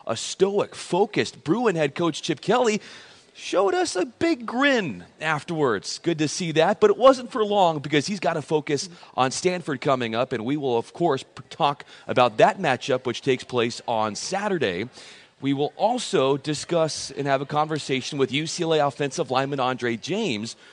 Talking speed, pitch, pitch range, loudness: 175 wpm, 155 Hz, 135-185 Hz, -24 LUFS